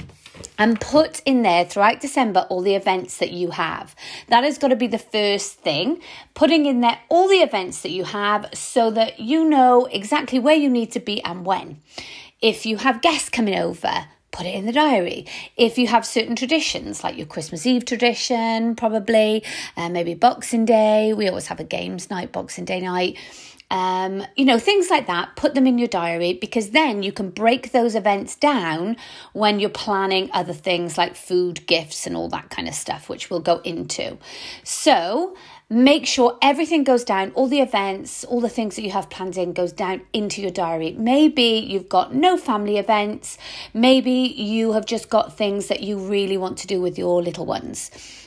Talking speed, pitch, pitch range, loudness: 195 wpm, 220 Hz, 185-250 Hz, -20 LUFS